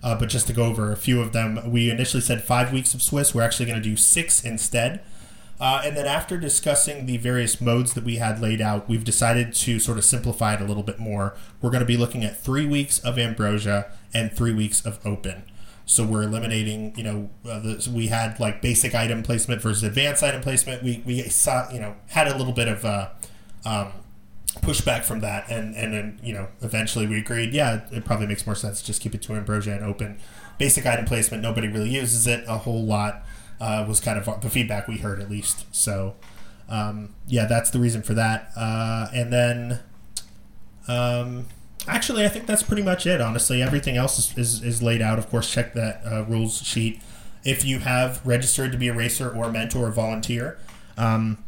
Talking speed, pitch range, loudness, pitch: 220 wpm, 105-120 Hz, -23 LUFS, 115 Hz